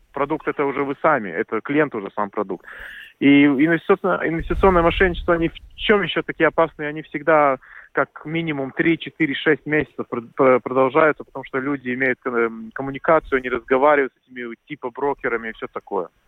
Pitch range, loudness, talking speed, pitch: 130-160 Hz, -20 LUFS, 150 wpm, 145 Hz